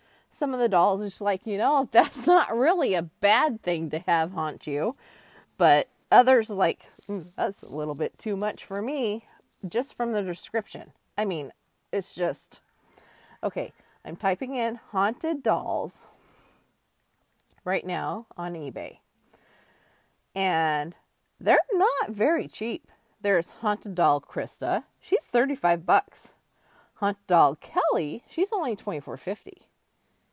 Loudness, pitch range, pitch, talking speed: -26 LUFS, 175-240 Hz, 205 Hz, 130 wpm